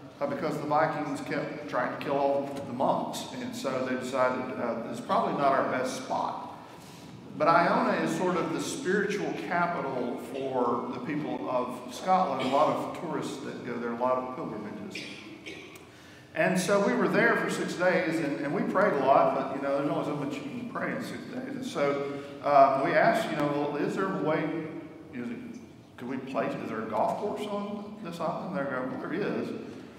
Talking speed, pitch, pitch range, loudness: 200 wpm, 145 Hz, 135-180 Hz, -29 LUFS